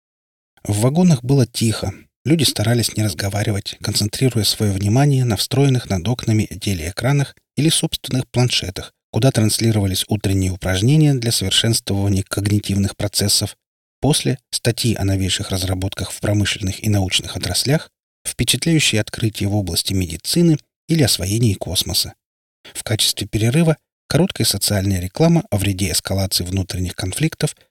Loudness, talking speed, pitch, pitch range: -18 LUFS, 120 wpm, 105 Hz, 100-125 Hz